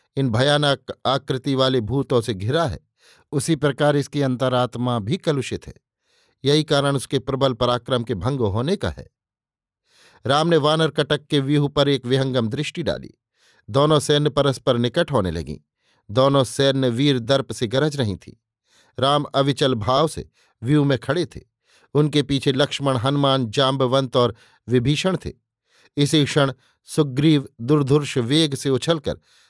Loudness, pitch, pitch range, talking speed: -20 LUFS, 135 Hz, 125-145 Hz, 150 wpm